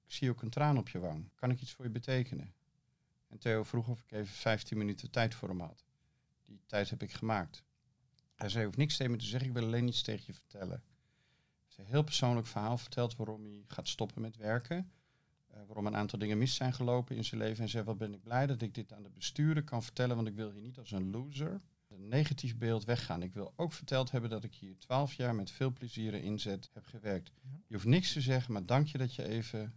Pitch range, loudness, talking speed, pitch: 110-130 Hz, -37 LUFS, 255 wpm, 115 Hz